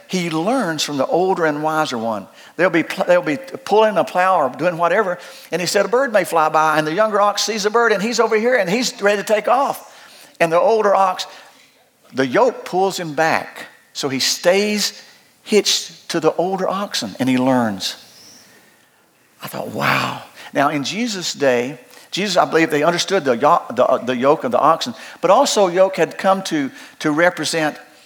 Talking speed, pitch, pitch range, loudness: 190 wpm, 185 Hz, 160-210 Hz, -17 LUFS